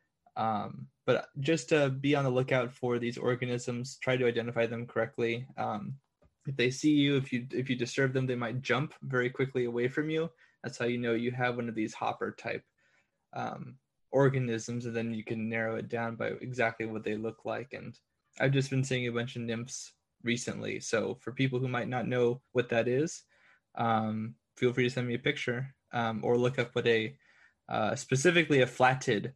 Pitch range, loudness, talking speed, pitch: 115-130 Hz, -31 LUFS, 200 wpm, 125 Hz